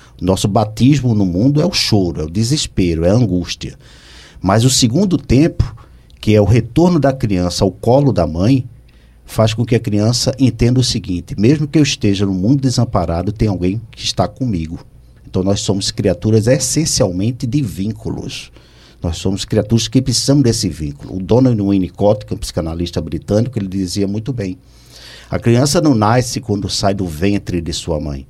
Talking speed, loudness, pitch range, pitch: 180 wpm, -15 LUFS, 90-125 Hz, 105 Hz